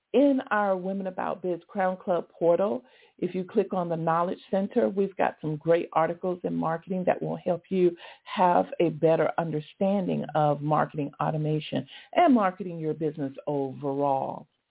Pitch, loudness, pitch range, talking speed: 175 Hz, -27 LUFS, 155-195 Hz, 155 wpm